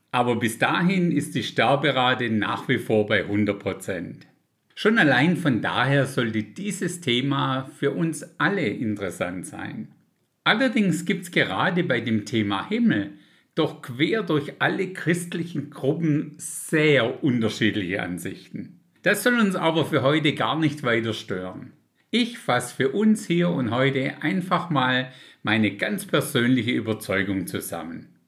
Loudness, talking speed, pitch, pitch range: -23 LUFS, 135 wpm, 140 Hz, 115-170 Hz